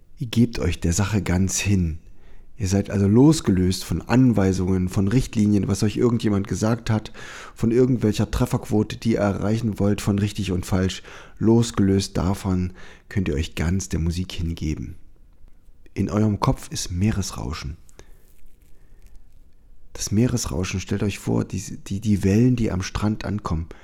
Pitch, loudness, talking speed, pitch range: 100 Hz, -22 LUFS, 145 wpm, 90-110 Hz